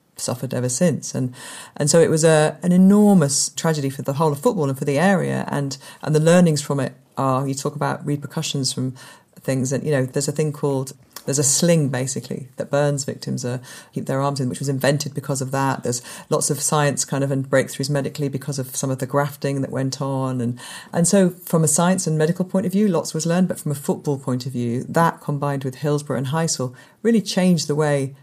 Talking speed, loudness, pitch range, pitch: 230 wpm, -20 LUFS, 135-160 Hz, 145 Hz